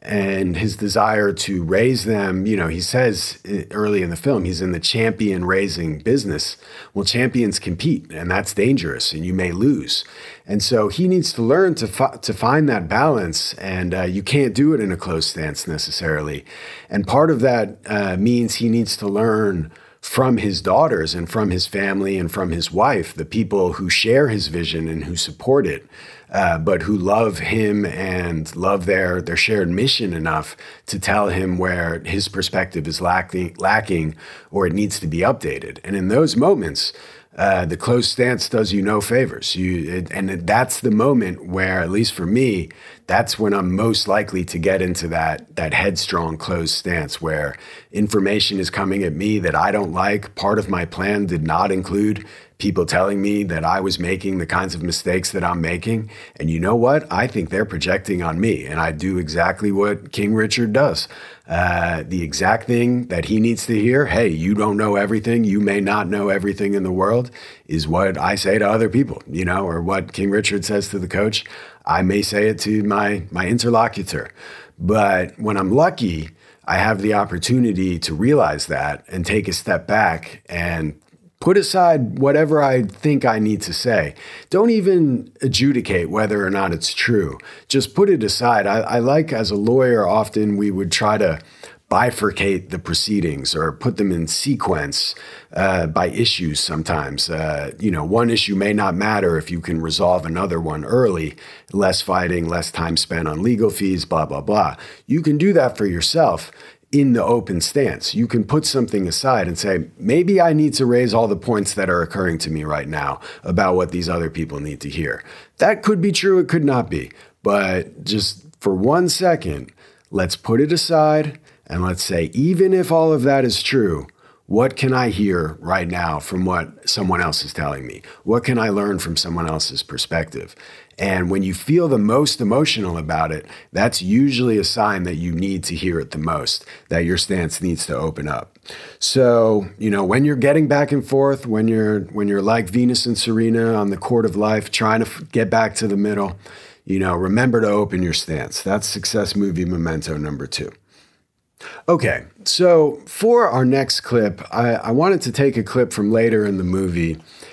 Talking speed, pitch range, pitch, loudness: 195 wpm, 90-115 Hz, 100 Hz, -19 LUFS